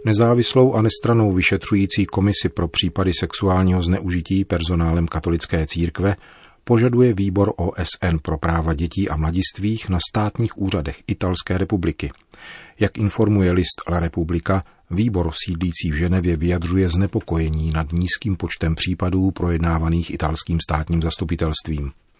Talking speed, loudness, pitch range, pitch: 120 wpm, -20 LUFS, 85-100 Hz, 90 Hz